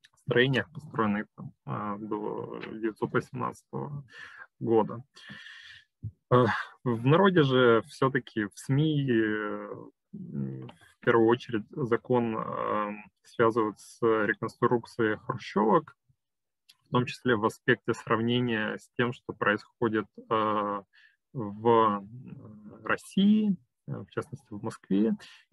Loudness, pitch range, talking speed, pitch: -28 LUFS, 110-130 Hz, 80 wpm, 115 Hz